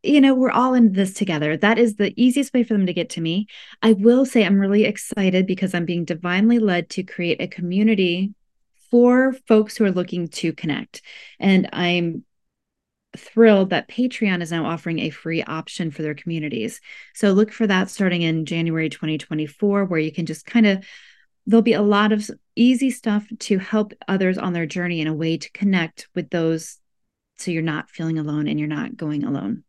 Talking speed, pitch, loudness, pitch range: 200 wpm, 190 Hz, -20 LUFS, 165-220 Hz